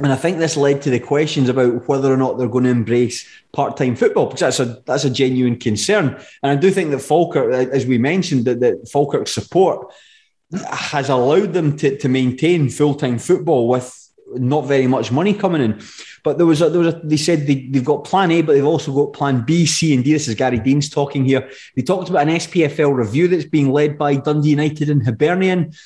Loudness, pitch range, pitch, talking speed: -17 LUFS, 130-160 Hz, 140 Hz, 225 wpm